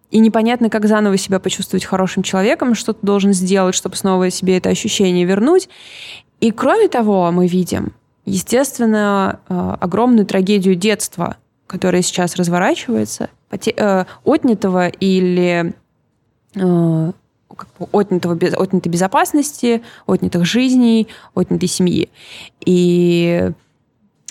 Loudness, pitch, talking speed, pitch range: -15 LUFS, 190 Hz, 105 wpm, 180-215 Hz